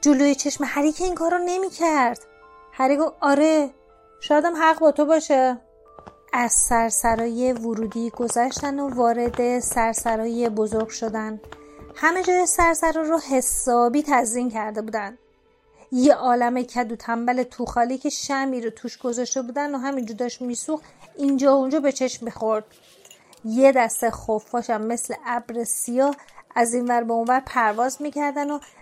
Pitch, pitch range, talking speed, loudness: 245 Hz, 230-285 Hz, 140 wpm, -22 LUFS